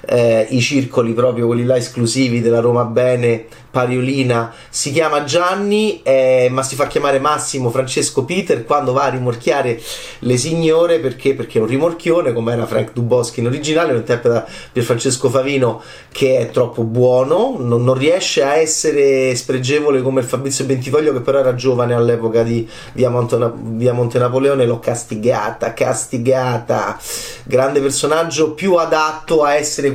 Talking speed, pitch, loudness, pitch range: 155 wpm, 130 Hz, -16 LUFS, 120-145 Hz